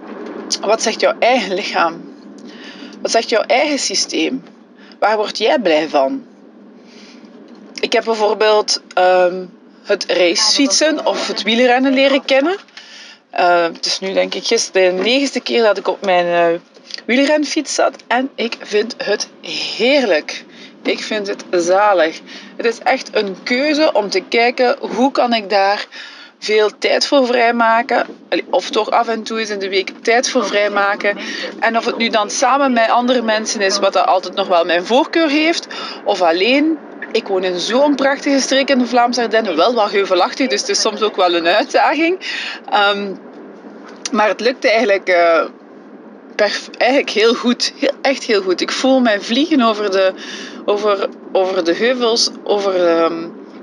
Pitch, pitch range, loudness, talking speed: 230 Hz, 200-270 Hz, -15 LUFS, 165 wpm